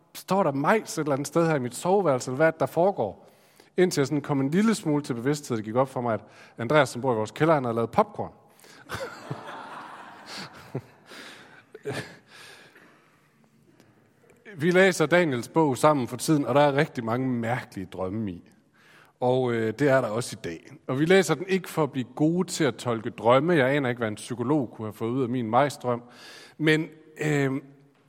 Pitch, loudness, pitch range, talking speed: 140 Hz, -25 LUFS, 120-155 Hz, 190 wpm